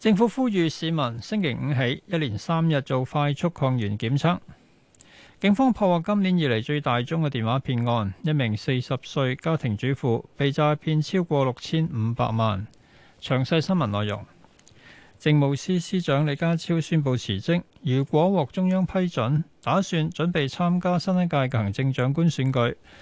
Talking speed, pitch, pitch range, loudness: 250 characters per minute, 150 Hz, 130-170 Hz, -24 LUFS